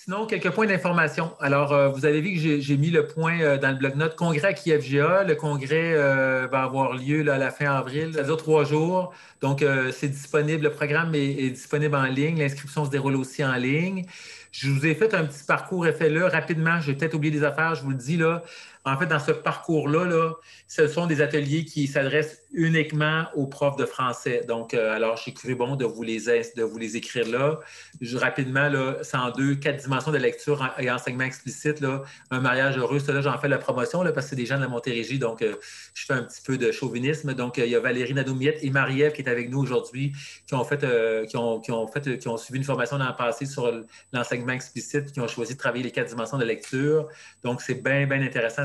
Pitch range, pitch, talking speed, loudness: 130-155 Hz, 140 Hz, 240 wpm, -25 LUFS